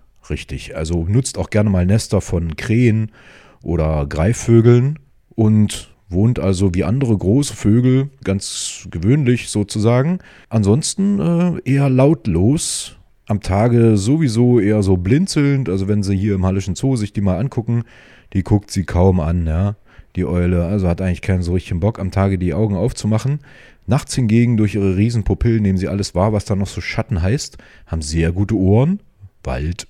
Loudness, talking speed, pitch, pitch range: -17 LUFS, 165 wpm, 105 Hz, 95-120 Hz